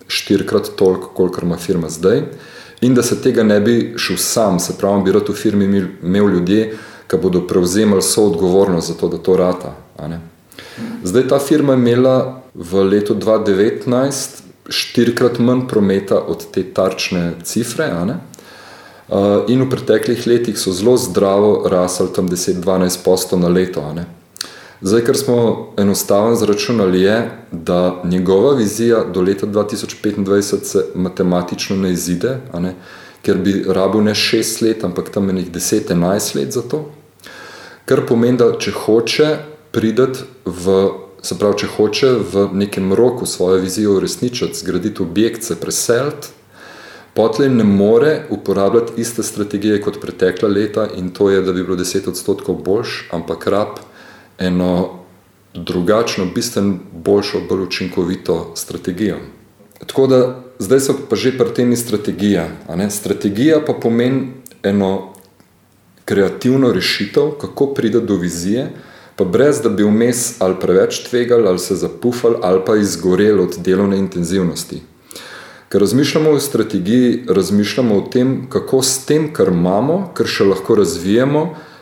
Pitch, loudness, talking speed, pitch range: 100 Hz, -15 LUFS, 135 wpm, 95-120 Hz